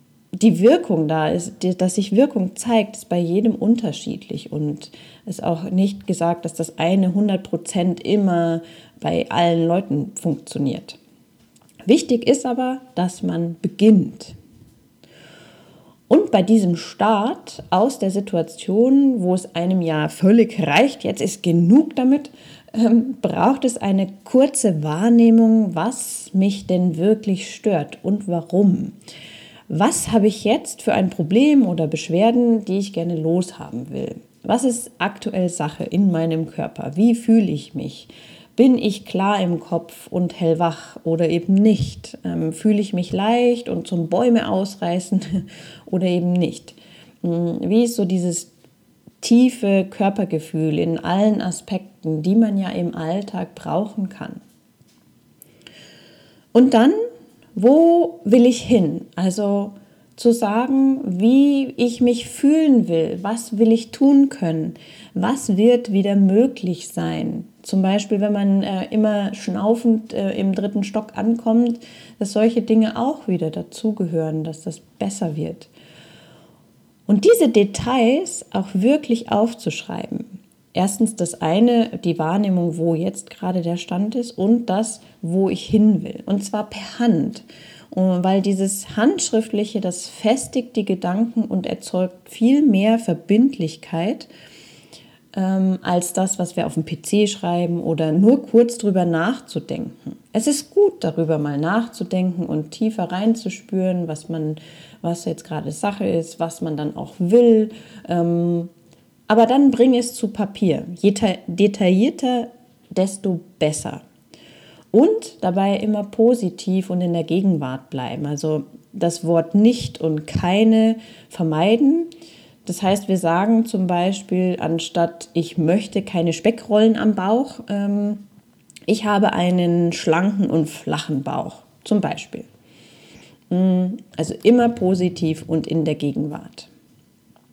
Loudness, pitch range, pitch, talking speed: -19 LUFS, 170-225 Hz, 195 Hz, 130 wpm